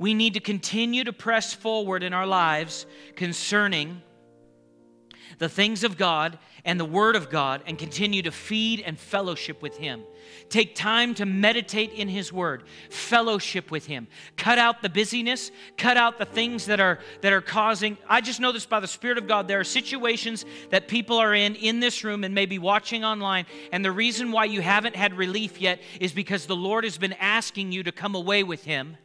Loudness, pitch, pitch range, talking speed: -24 LUFS, 200 Hz, 175-220 Hz, 200 wpm